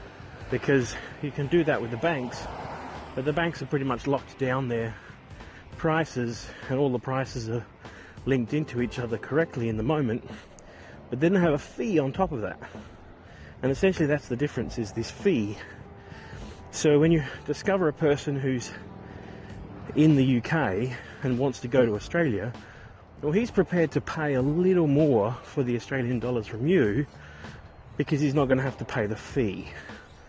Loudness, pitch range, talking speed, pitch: -27 LUFS, 115-150 Hz, 175 wpm, 130 Hz